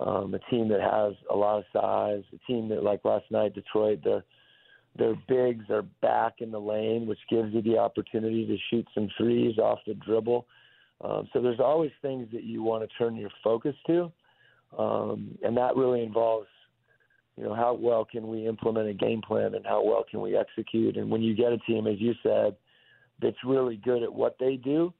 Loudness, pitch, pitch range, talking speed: -28 LUFS, 115 Hz, 110-120 Hz, 205 wpm